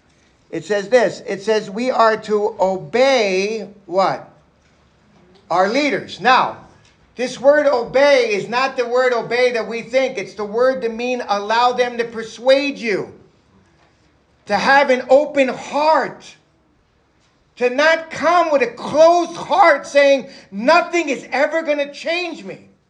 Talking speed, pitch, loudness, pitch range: 140 wpm, 250 Hz, -17 LUFS, 220-280 Hz